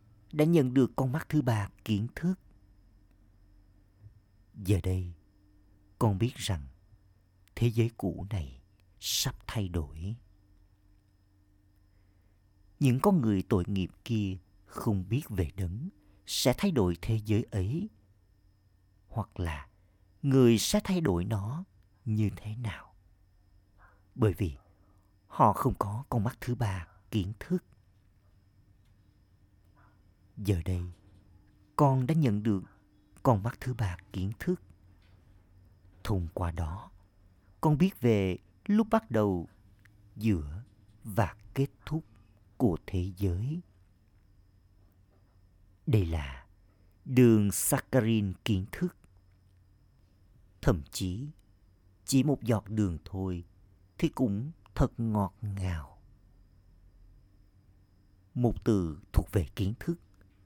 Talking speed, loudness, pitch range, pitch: 110 wpm, -31 LUFS, 95-110 Hz, 100 Hz